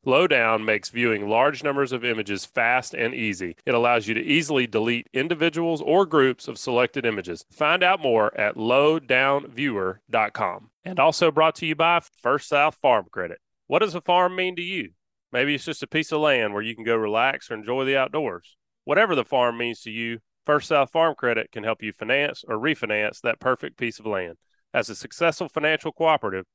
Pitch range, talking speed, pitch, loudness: 115-160 Hz, 195 wpm, 130 Hz, -23 LUFS